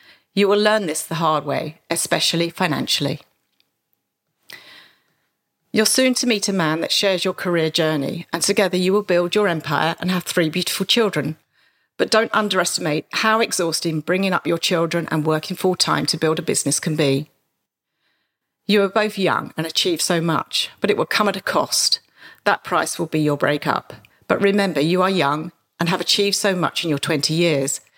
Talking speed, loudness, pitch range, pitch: 185 wpm, -19 LUFS, 155-200 Hz, 175 Hz